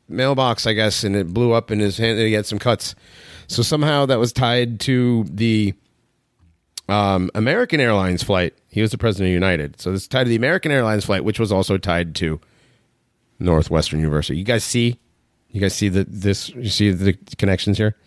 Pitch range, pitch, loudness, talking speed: 95-120 Hz, 105 Hz, -19 LUFS, 200 wpm